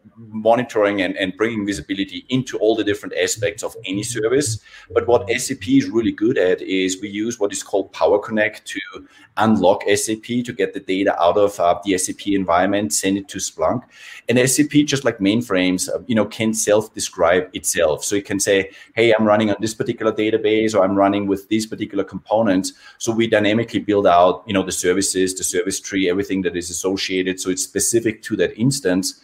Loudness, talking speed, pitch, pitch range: -19 LUFS, 195 wpm, 105 Hz, 95-115 Hz